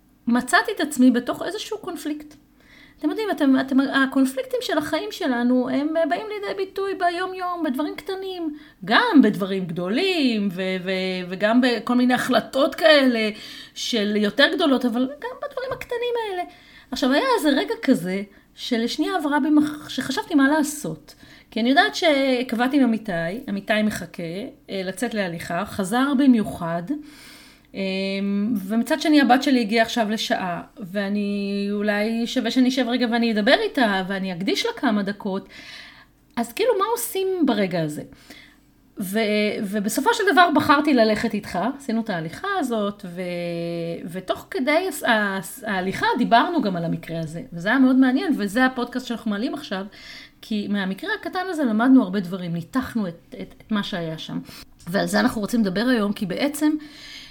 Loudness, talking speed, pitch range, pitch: -22 LUFS, 145 wpm, 205-300 Hz, 245 Hz